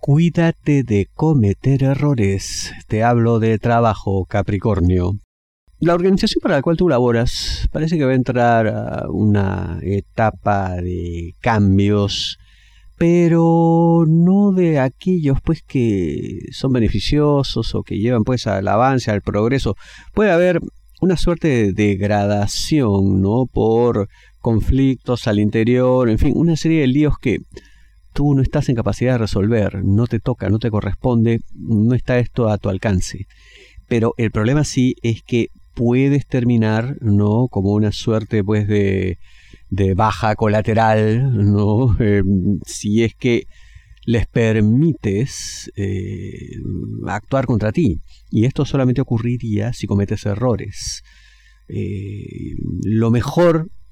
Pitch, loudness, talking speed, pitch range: 110 Hz, -17 LUFS, 130 wpm, 100-130 Hz